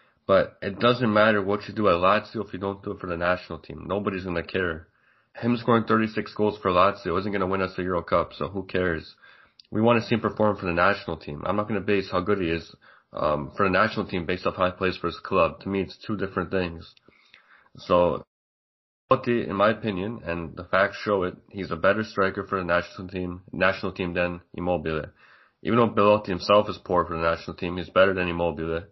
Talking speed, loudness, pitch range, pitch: 230 wpm, -25 LUFS, 90-105 Hz, 95 Hz